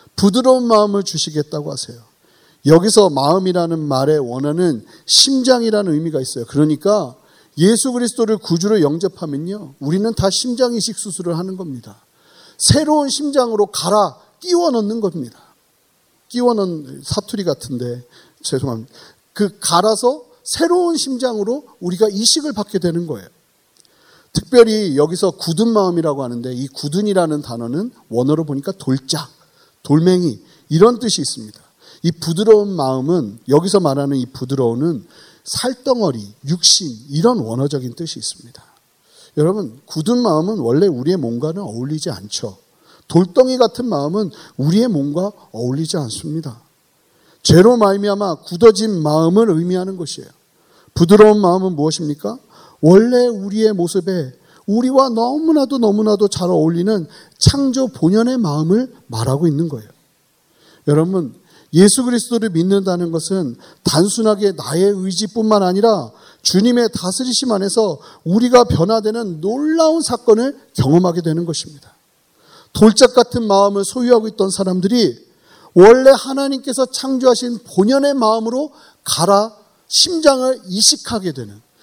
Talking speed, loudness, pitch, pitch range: 320 characters per minute, -15 LUFS, 190 Hz, 155-230 Hz